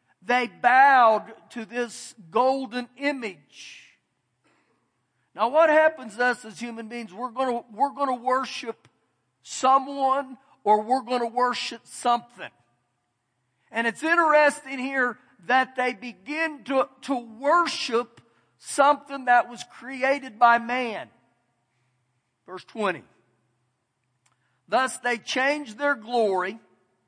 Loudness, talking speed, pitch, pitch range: -24 LUFS, 115 wpm, 245 Hz, 200-265 Hz